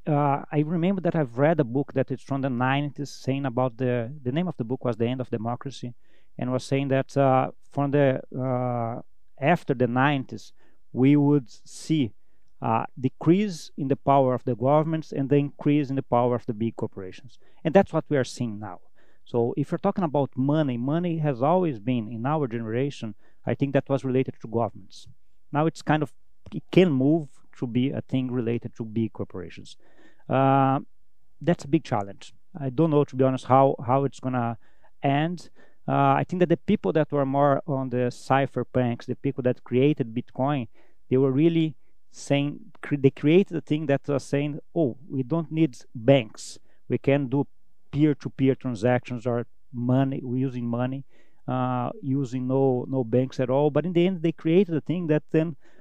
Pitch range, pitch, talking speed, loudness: 125-145 Hz, 135 Hz, 190 wpm, -25 LUFS